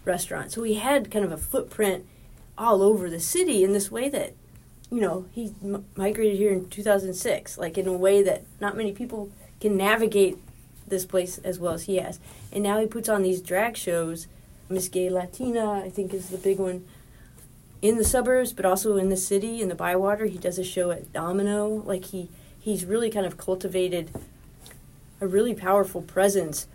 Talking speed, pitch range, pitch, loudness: 195 wpm, 180-210 Hz, 195 Hz, -25 LUFS